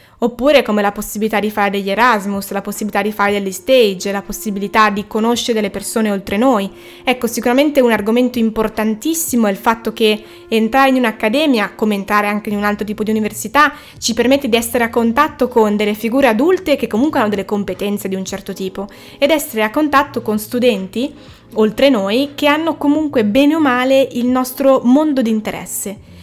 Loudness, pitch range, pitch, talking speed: -15 LUFS, 210-265 Hz, 225 Hz, 185 wpm